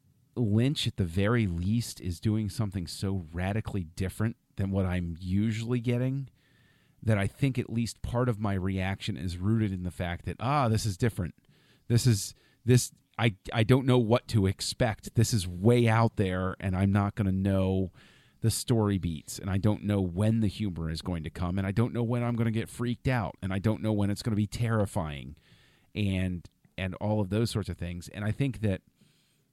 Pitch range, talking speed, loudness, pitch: 95-120 Hz, 205 wpm, -29 LUFS, 105 Hz